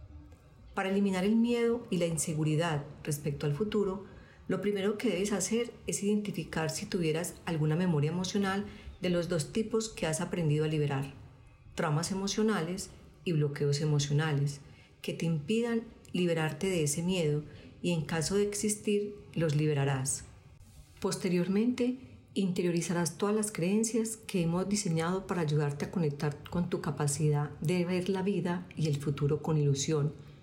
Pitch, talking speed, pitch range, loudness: 175 Hz, 145 wpm, 150-200 Hz, -32 LUFS